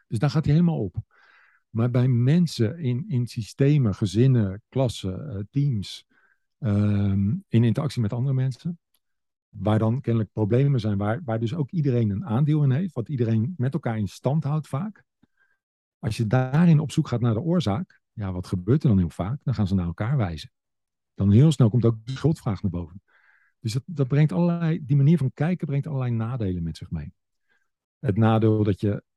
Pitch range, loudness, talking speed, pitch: 105-145 Hz, -24 LUFS, 190 wpm, 120 Hz